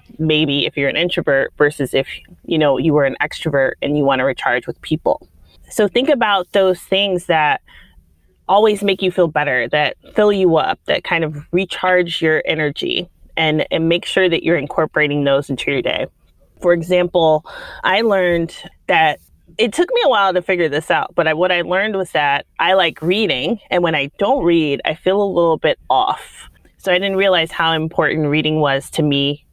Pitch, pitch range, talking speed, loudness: 165 Hz, 150-185 Hz, 195 wpm, -16 LUFS